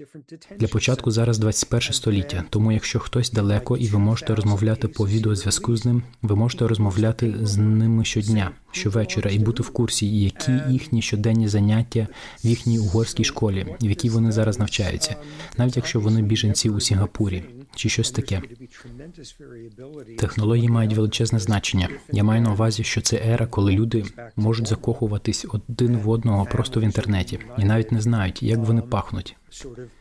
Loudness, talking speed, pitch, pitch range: -22 LUFS, 155 wpm, 110 Hz, 105-115 Hz